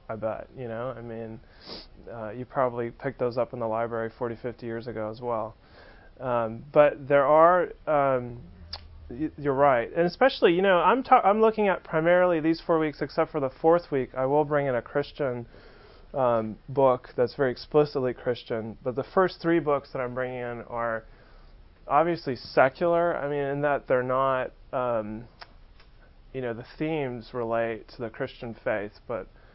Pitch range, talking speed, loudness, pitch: 115-150 Hz, 175 wpm, -26 LUFS, 130 Hz